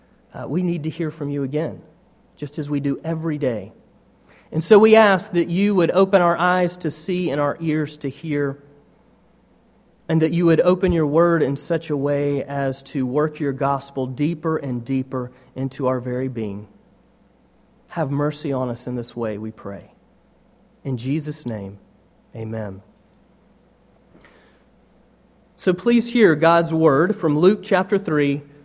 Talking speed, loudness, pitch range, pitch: 160 wpm, -20 LUFS, 135-170 Hz, 150 Hz